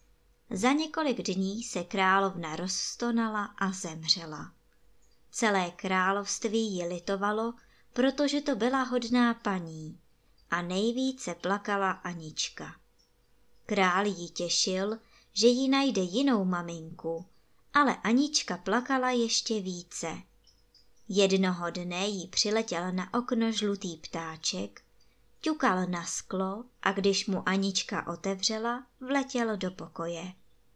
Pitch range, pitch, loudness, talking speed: 180-235 Hz, 195 Hz, -30 LUFS, 105 wpm